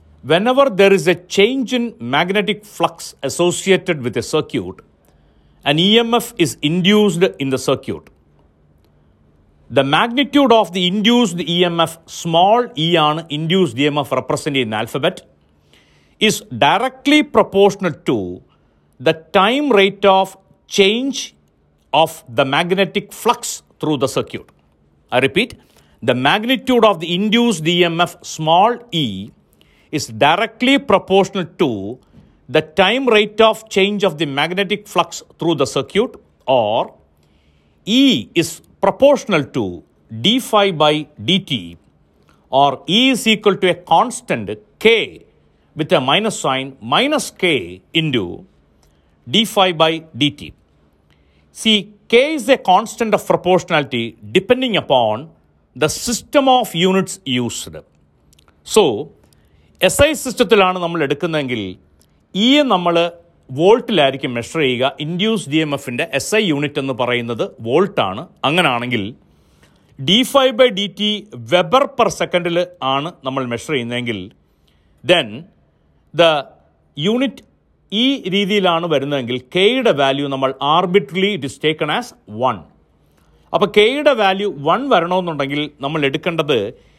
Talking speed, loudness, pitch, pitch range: 120 wpm, -16 LUFS, 170 Hz, 135-205 Hz